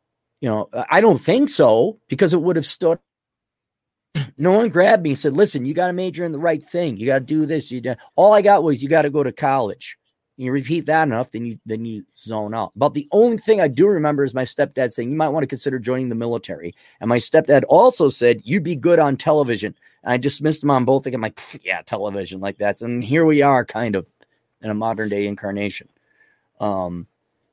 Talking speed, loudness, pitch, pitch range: 240 wpm, -18 LUFS, 135 Hz, 115-160 Hz